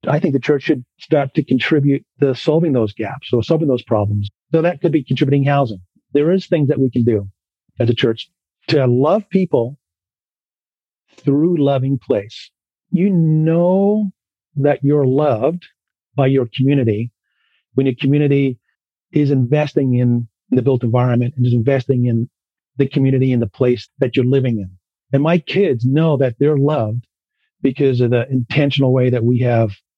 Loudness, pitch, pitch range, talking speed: -17 LUFS, 135 Hz, 120-150 Hz, 165 wpm